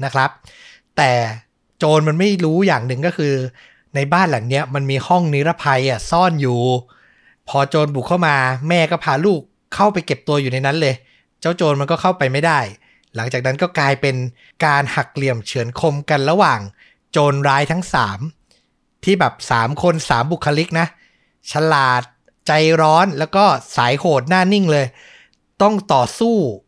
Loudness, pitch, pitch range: -17 LUFS, 145 Hz, 130-170 Hz